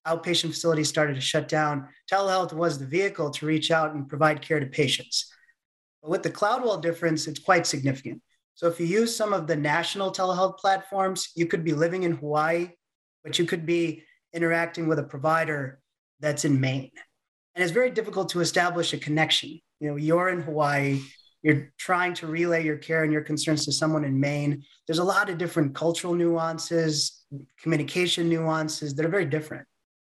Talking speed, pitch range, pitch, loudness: 185 wpm, 150-175 Hz, 160 Hz, -26 LUFS